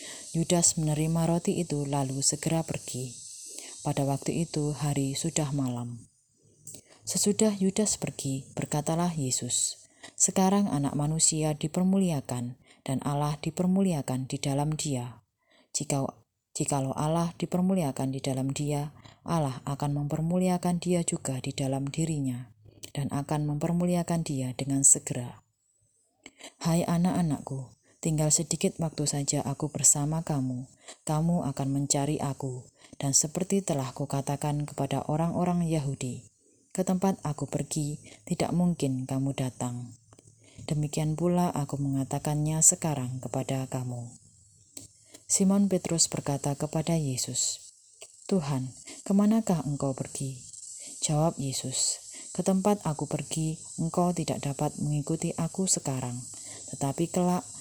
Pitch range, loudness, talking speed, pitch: 135-165 Hz, -28 LUFS, 110 wpm, 145 Hz